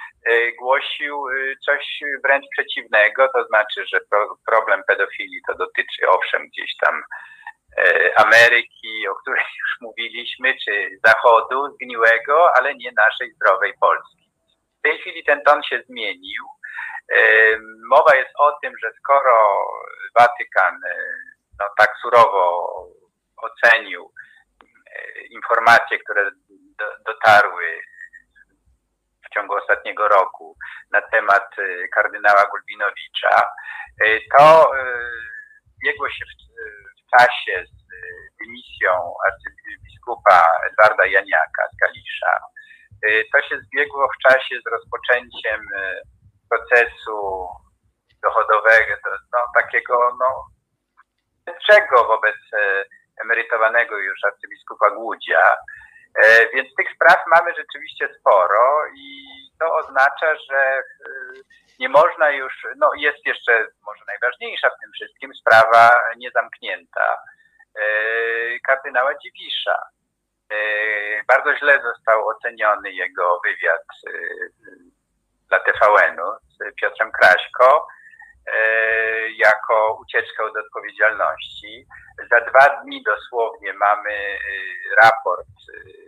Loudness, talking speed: -17 LUFS, 95 wpm